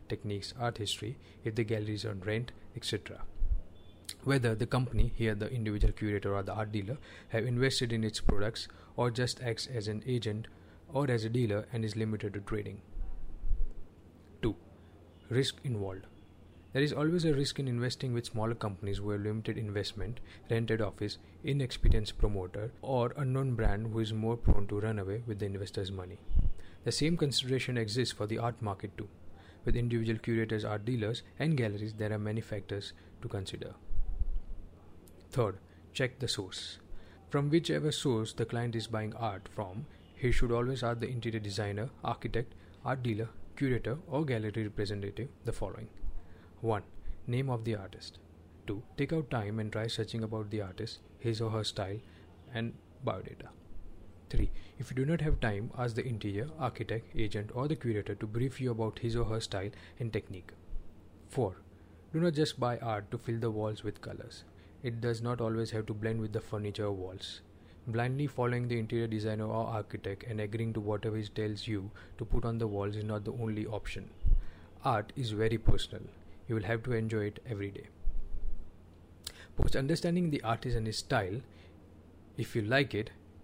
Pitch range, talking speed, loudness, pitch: 100-120 Hz, 175 wpm, -35 LUFS, 110 Hz